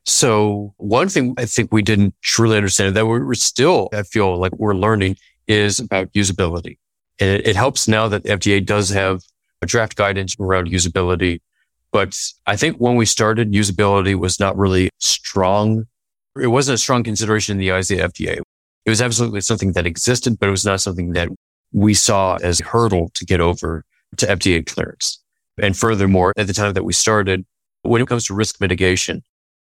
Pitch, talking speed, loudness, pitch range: 100 Hz, 190 wpm, -17 LUFS, 95-110 Hz